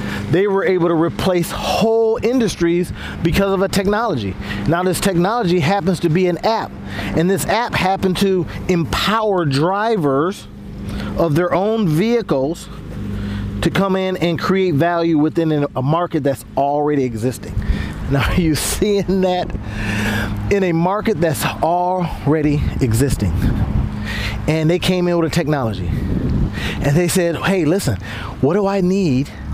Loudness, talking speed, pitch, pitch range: -18 LUFS, 140 wpm, 170 Hz, 130-185 Hz